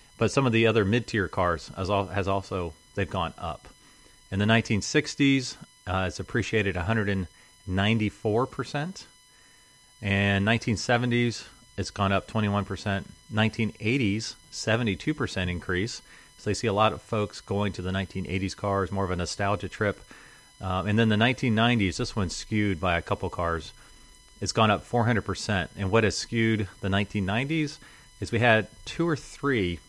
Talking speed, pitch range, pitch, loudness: 150 wpm, 95-115 Hz, 105 Hz, -27 LUFS